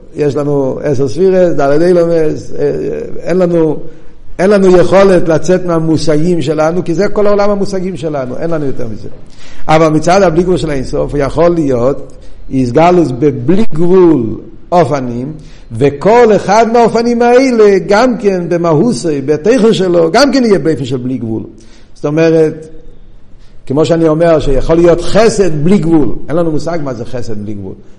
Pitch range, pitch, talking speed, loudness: 145-185 Hz, 165 Hz, 150 wpm, -10 LUFS